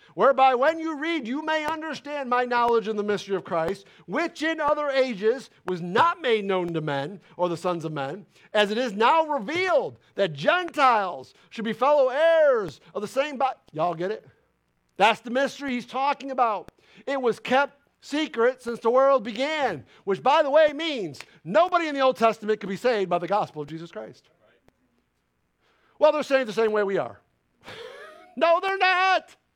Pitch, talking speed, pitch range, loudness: 260 Hz, 185 wpm, 210-300 Hz, -24 LUFS